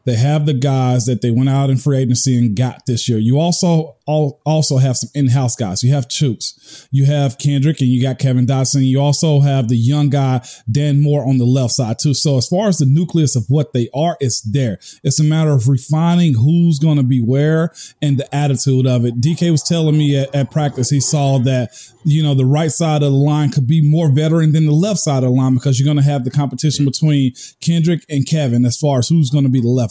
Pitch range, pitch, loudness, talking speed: 130-150 Hz, 140 Hz, -15 LUFS, 250 wpm